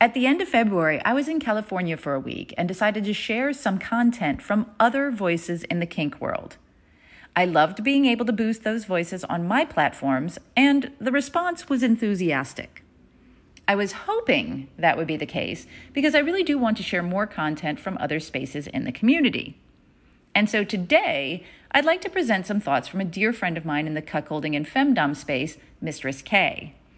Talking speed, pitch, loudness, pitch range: 195 wpm, 205 Hz, -24 LUFS, 155-255 Hz